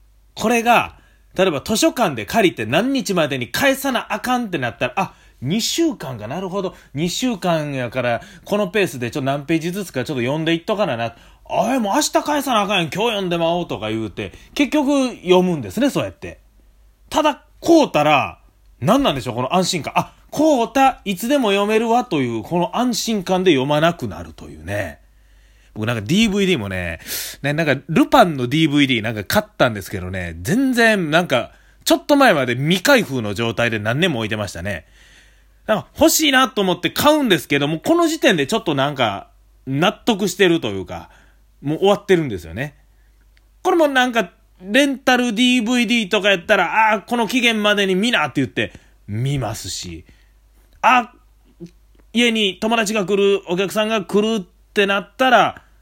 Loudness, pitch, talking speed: -18 LUFS, 185 Hz, 360 characters per minute